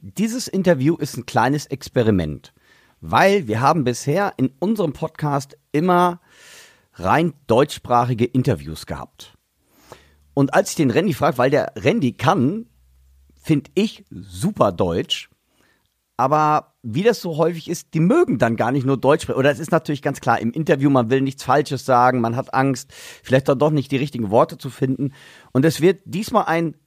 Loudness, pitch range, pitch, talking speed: -19 LUFS, 125-165 Hz, 145 Hz, 170 wpm